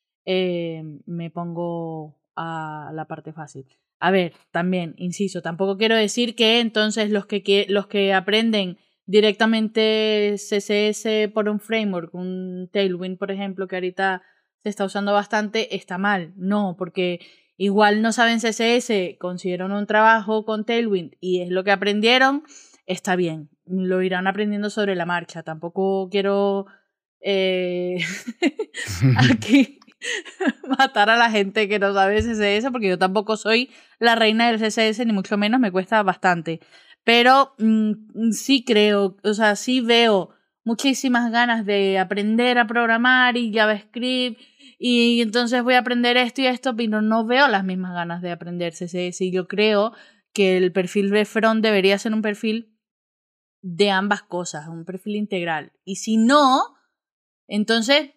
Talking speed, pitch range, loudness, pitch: 150 wpm, 185-225 Hz, -20 LUFS, 205 Hz